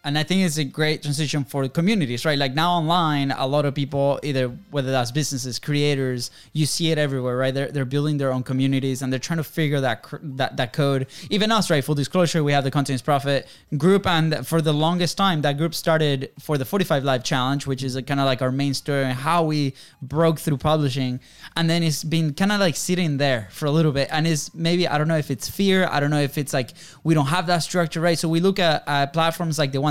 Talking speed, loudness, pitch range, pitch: 245 wpm, -22 LUFS, 135-165 Hz, 150 Hz